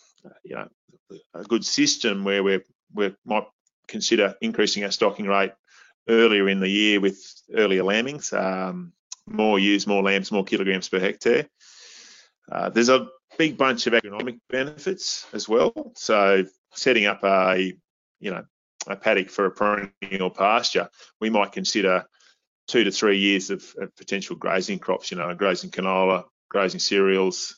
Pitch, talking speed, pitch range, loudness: 100 Hz, 155 wpm, 95-115 Hz, -22 LUFS